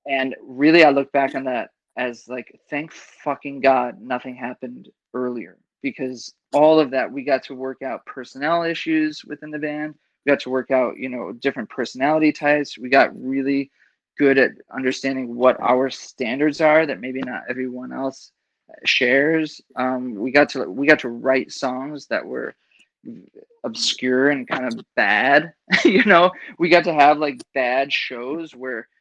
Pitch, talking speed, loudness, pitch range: 135 Hz, 170 wpm, -20 LUFS, 130-150 Hz